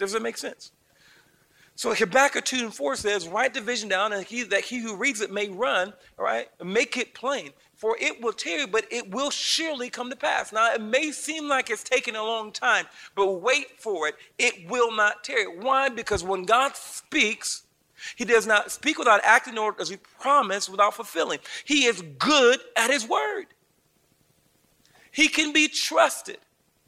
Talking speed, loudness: 190 wpm, -24 LUFS